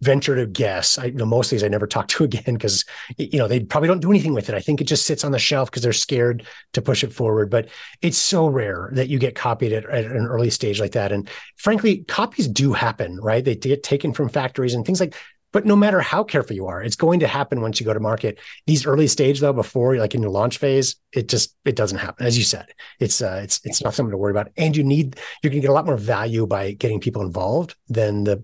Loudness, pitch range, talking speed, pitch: -20 LUFS, 110-145 Hz, 270 wpm, 125 Hz